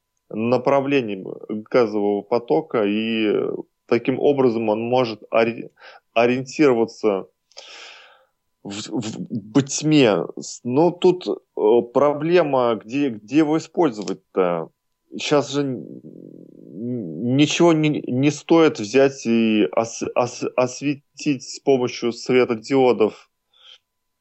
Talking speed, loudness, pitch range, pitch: 90 wpm, -20 LUFS, 115-145 Hz, 125 Hz